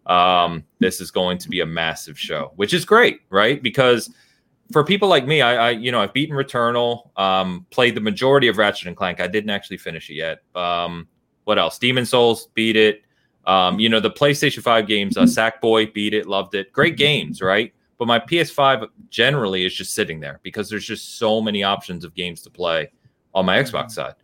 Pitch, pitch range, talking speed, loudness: 110 Hz, 90-120 Hz, 210 wpm, -19 LUFS